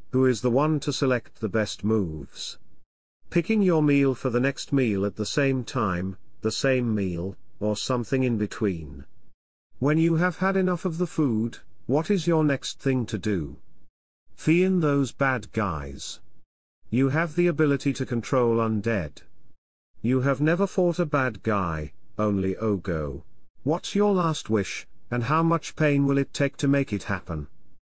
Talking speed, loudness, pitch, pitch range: 170 wpm, -25 LUFS, 125 Hz, 100-145 Hz